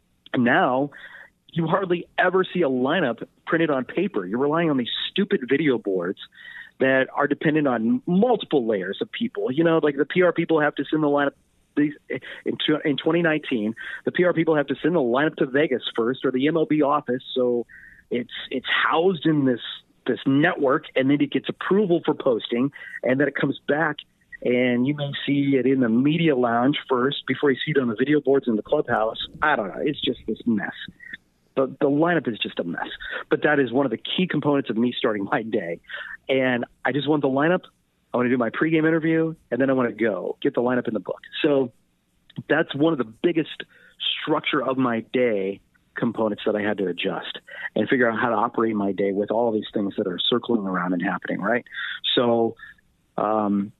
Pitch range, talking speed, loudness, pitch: 120-160 Hz, 205 wpm, -23 LUFS, 140 Hz